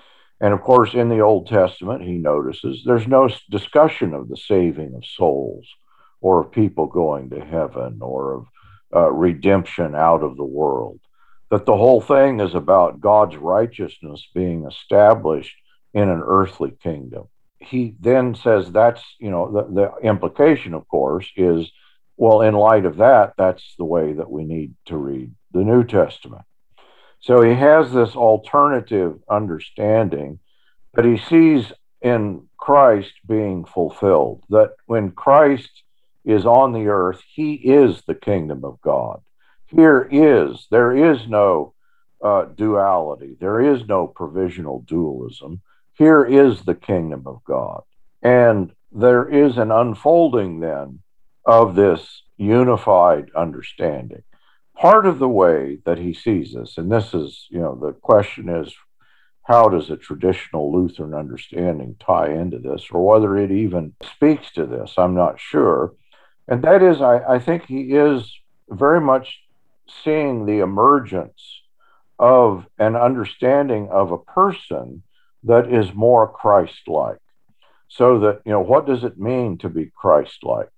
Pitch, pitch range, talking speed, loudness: 105 Hz, 90-125 Hz, 145 wpm, -17 LUFS